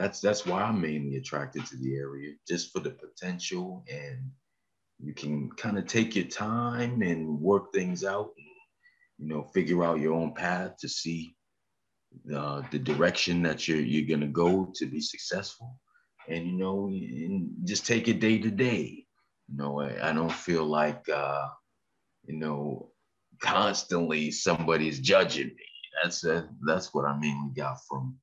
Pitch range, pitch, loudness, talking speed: 75-110 Hz, 85 Hz, -30 LUFS, 170 wpm